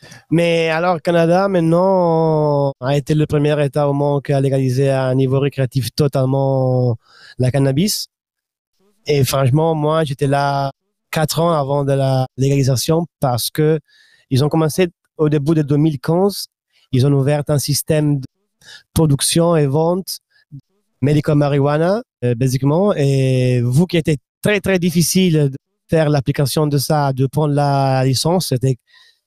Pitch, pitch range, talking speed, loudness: 150 Hz, 135-165 Hz, 140 wpm, -16 LUFS